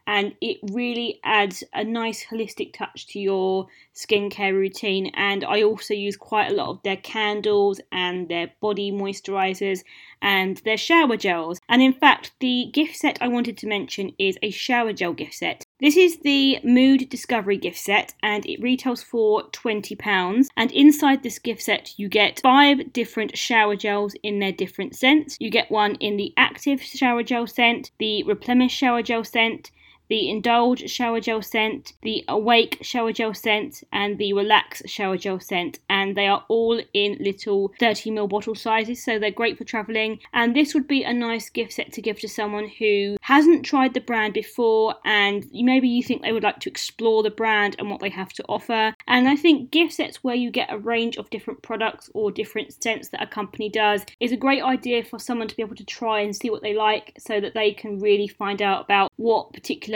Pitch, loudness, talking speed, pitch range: 220 Hz, -22 LUFS, 200 wpm, 205-245 Hz